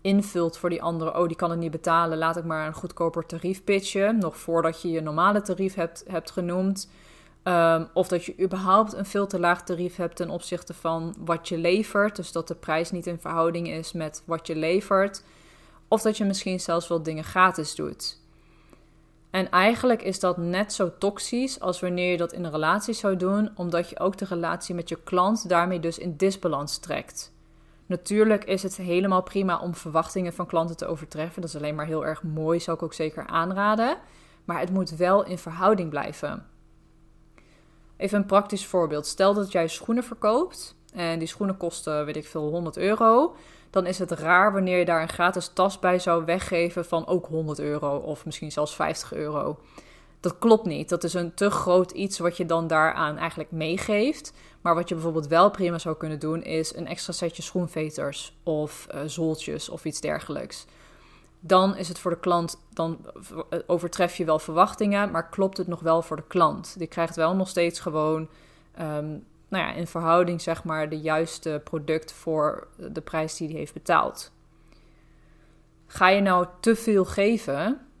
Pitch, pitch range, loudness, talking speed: 175 Hz, 160-190 Hz, -26 LUFS, 190 wpm